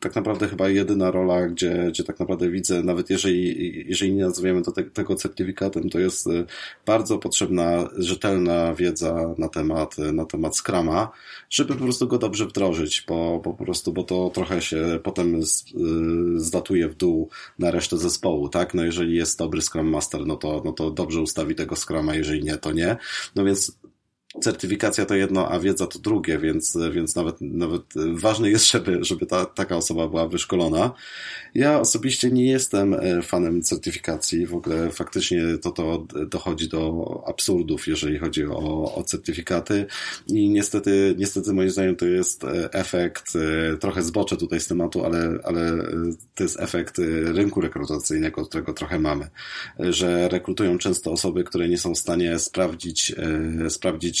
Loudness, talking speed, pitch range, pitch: -23 LUFS, 160 wpm, 80-95 Hz, 85 Hz